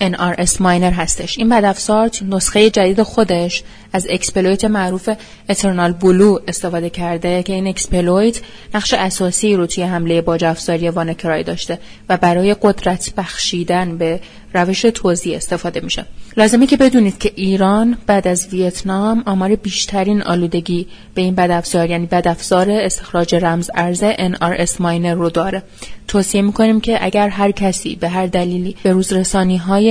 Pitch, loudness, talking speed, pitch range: 185 Hz, -15 LUFS, 140 wpm, 175-205 Hz